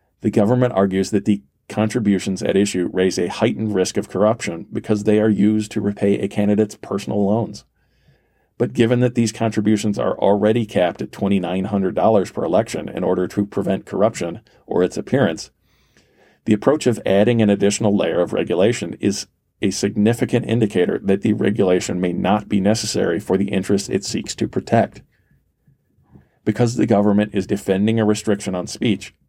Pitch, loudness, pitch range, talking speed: 105 Hz, -19 LUFS, 100-110 Hz, 165 wpm